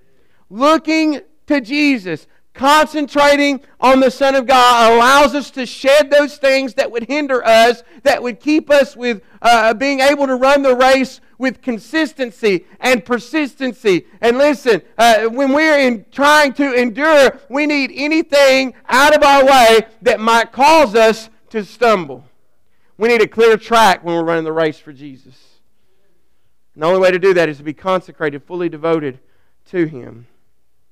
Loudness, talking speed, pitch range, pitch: -13 LUFS, 165 wpm, 195-280 Hz, 245 Hz